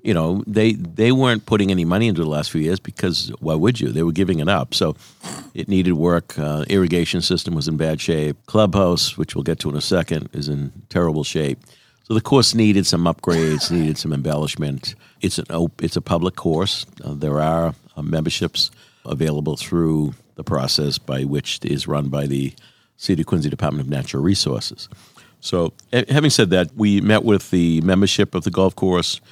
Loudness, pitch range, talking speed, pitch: -19 LUFS, 75-100 Hz, 200 wpm, 85 Hz